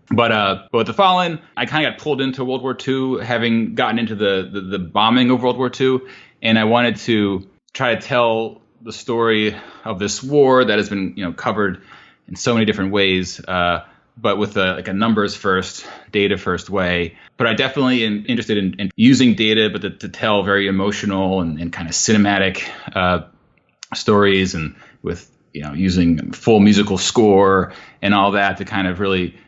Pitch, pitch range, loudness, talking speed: 100 Hz, 95-120 Hz, -17 LUFS, 195 wpm